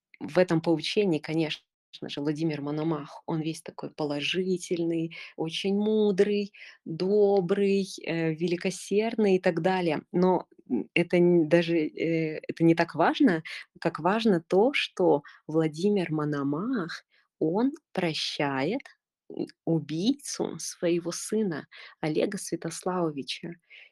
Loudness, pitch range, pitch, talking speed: -27 LUFS, 160-195 Hz, 170 Hz, 95 wpm